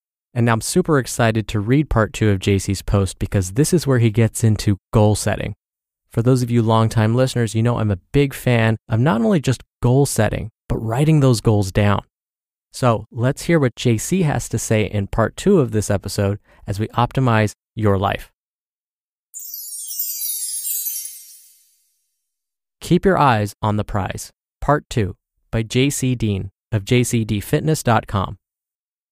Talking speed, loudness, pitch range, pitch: 155 wpm, -19 LUFS, 105-130 Hz, 115 Hz